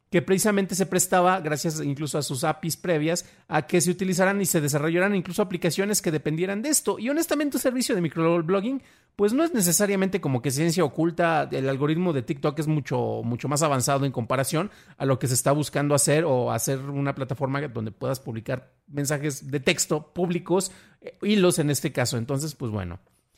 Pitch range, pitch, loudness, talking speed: 140-185 Hz, 160 Hz, -25 LUFS, 185 wpm